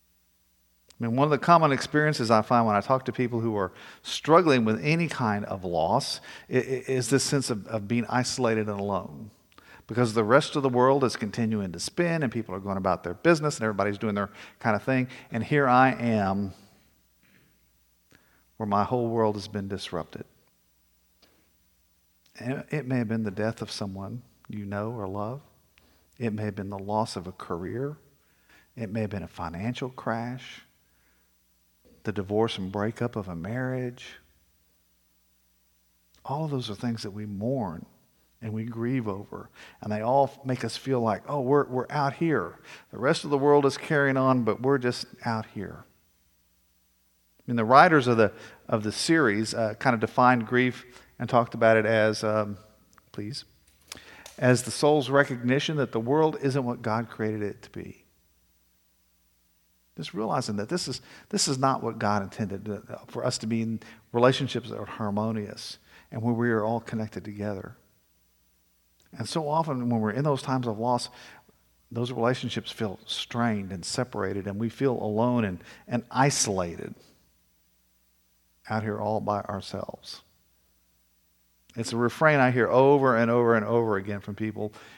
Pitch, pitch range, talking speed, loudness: 110 Hz, 100-125 Hz, 170 wpm, -26 LUFS